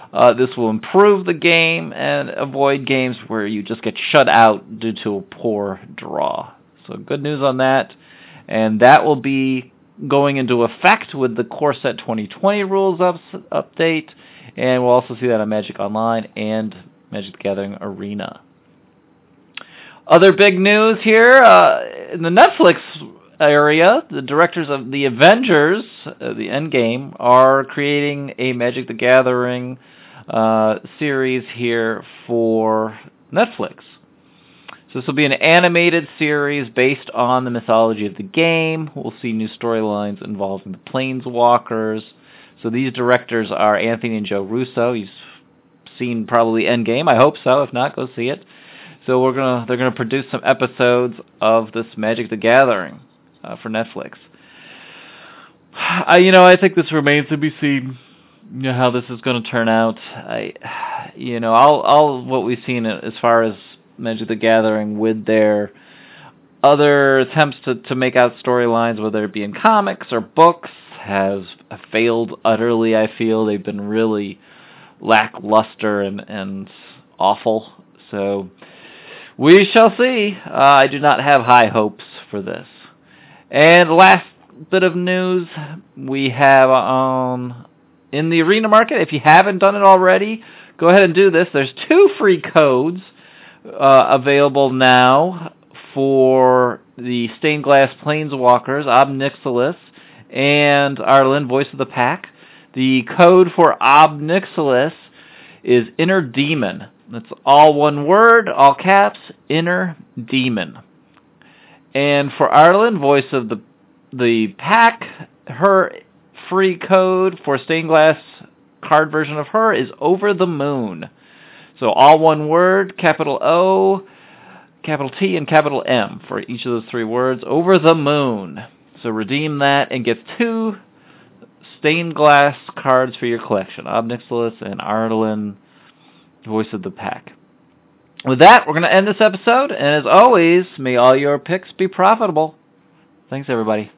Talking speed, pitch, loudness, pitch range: 145 wpm, 135 Hz, -15 LUFS, 115-160 Hz